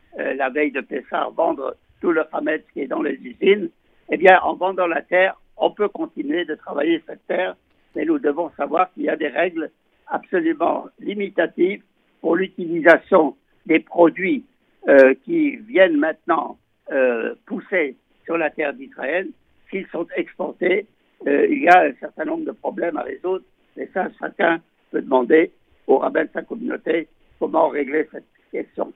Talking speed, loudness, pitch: 165 wpm, -20 LUFS, 185 Hz